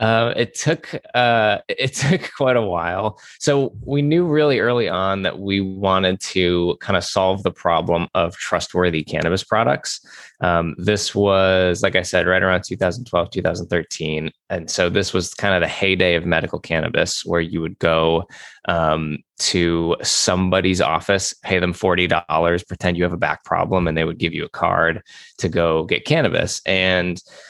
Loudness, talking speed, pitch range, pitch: -19 LUFS, 170 wpm, 85-100 Hz, 90 Hz